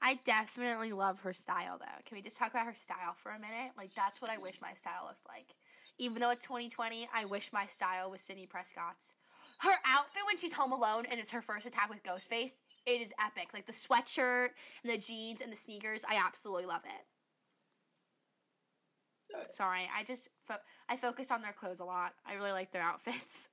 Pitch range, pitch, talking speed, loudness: 195-245 Hz, 225 Hz, 205 wpm, -38 LUFS